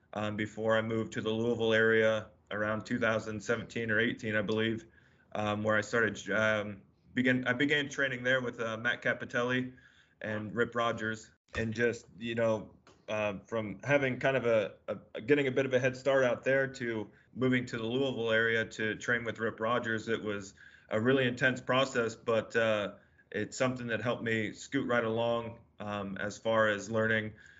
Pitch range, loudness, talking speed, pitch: 110-125 Hz, -32 LUFS, 180 wpm, 115 Hz